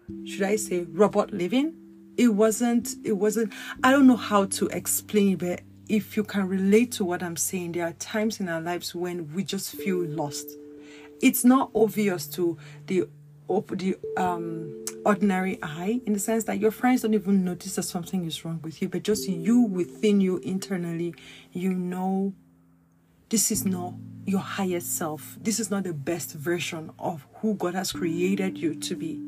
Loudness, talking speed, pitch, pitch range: -26 LUFS, 180 wpm, 185 Hz, 165-210 Hz